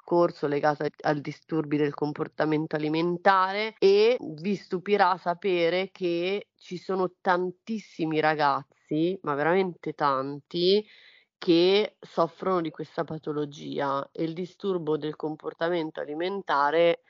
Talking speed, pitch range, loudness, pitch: 100 wpm, 155-185 Hz, -27 LUFS, 170 Hz